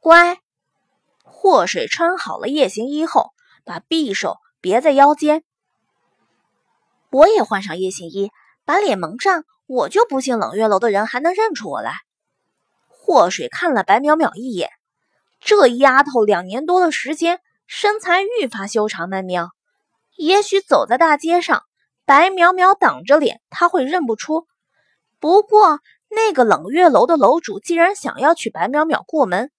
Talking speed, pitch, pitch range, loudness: 215 characters per minute, 310 Hz, 245-360 Hz, -16 LUFS